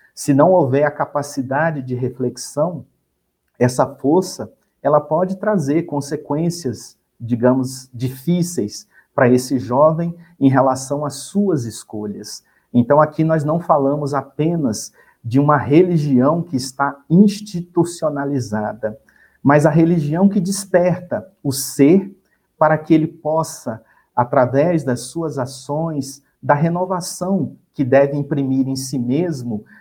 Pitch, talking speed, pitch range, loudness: 145 Hz, 115 wpm, 130-165 Hz, -18 LUFS